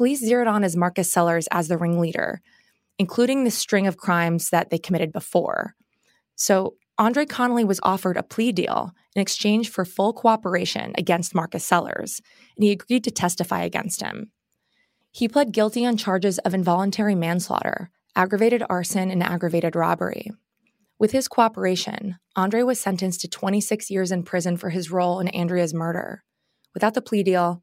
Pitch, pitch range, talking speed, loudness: 190 Hz, 175-220 Hz, 165 wpm, -23 LUFS